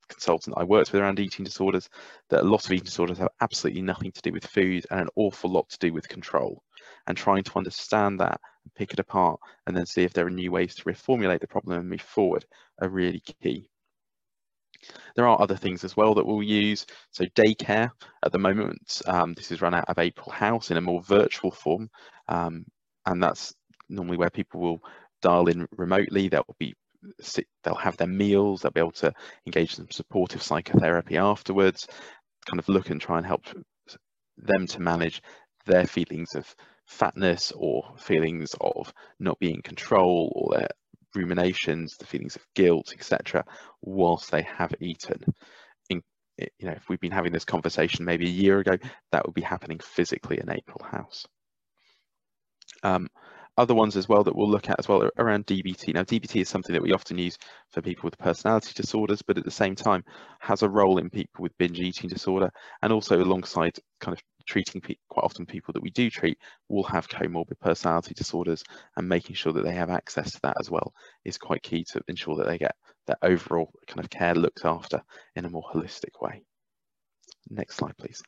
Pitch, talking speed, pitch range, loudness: 90 Hz, 195 wpm, 85-100 Hz, -26 LUFS